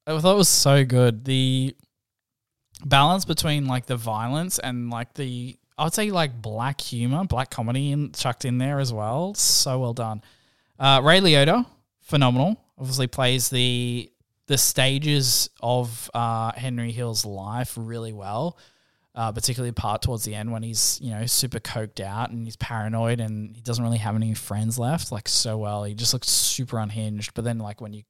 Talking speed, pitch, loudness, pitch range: 180 wpm, 120 Hz, -23 LUFS, 115-135 Hz